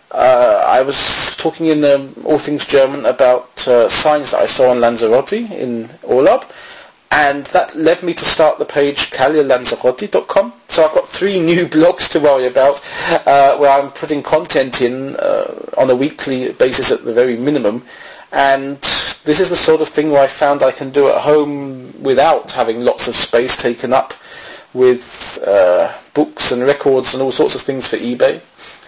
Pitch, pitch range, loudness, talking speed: 140 Hz, 135-160 Hz, -13 LUFS, 180 wpm